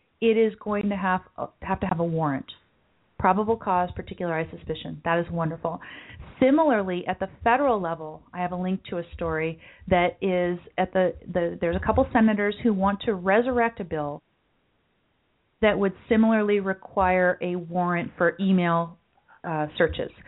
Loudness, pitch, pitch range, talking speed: -25 LUFS, 185 Hz, 170-205 Hz, 160 wpm